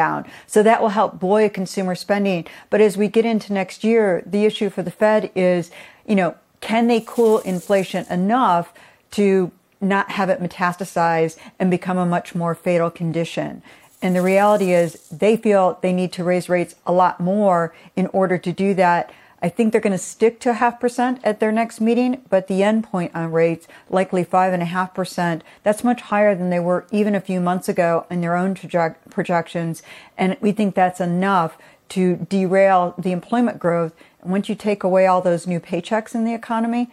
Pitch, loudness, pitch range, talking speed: 190 Hz, -19 LUFS, 175-210 Hz, 195 wpm